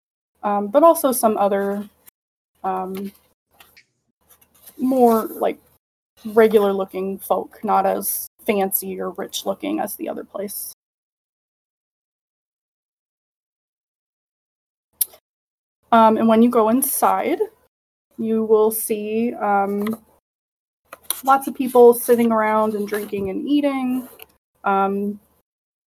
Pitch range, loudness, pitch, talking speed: 200-245 Hz, -19 LUFS, 220 Hz, 95 wpm